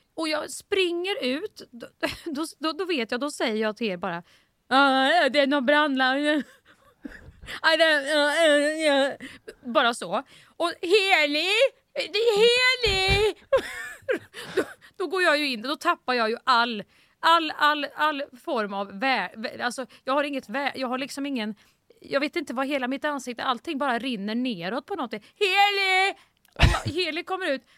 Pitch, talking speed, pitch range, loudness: 290 Hz, 145 wpm, 255-345 Hz, -24 LUFS